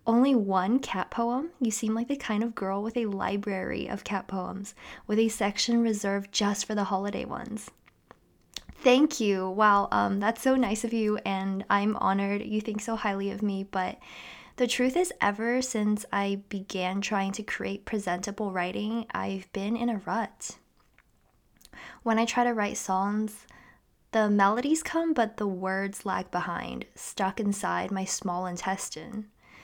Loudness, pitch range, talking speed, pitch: -28 LUFS, 195-230 Hz, 165 wpm, 210 Hz